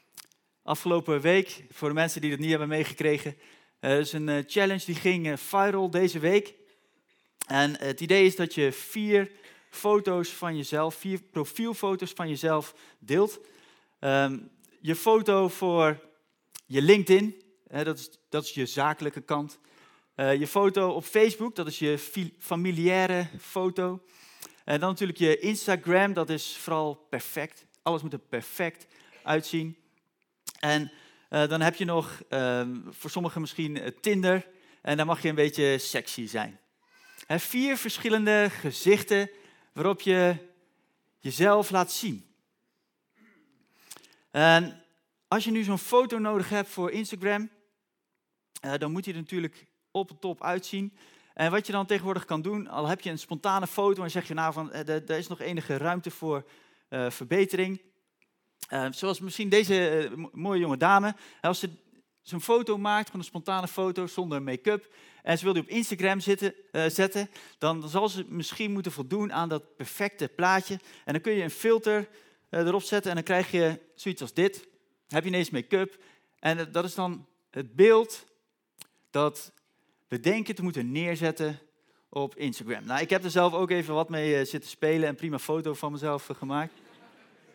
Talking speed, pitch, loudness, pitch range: 160 wpm, 175 Hz, -28 LUFS, 155-195 Hz